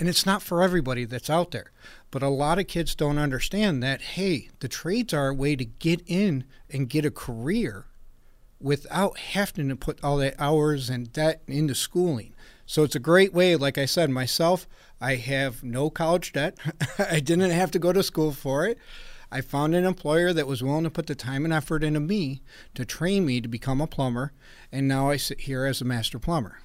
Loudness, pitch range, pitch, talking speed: -26 LUFS, 135-170 Hz, 150 Hz, 210 wpm